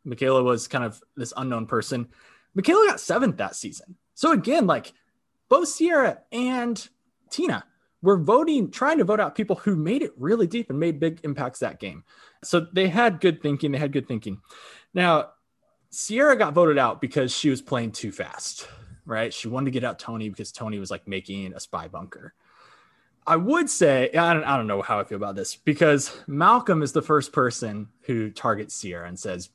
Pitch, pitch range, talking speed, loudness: 145 Hz, 115-195 Hz, 195 wpm, -23 LUFS